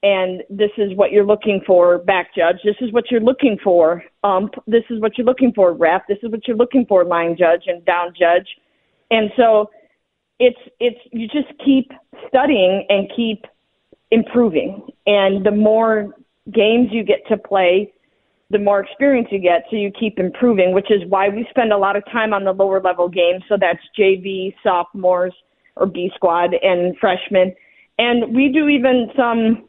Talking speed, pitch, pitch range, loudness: 180 wpm, 205 Hz, 185-235 Hz, -16 LUFS